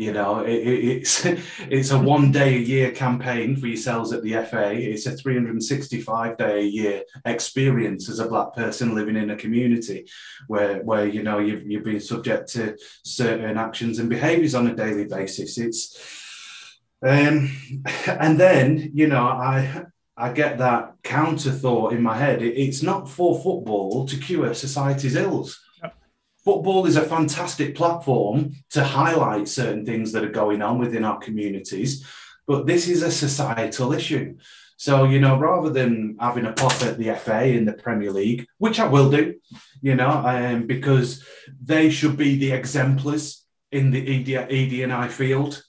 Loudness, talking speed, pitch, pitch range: -22 LUFS, 165 wpm, 130 Hz, 115-145 Hz